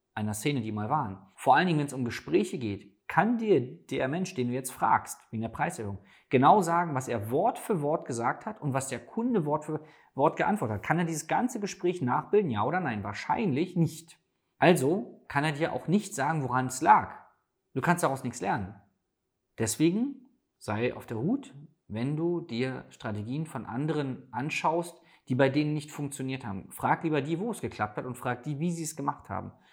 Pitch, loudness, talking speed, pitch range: 145 Hz, -29 LUFS, 205 wpm, 125-165 Hz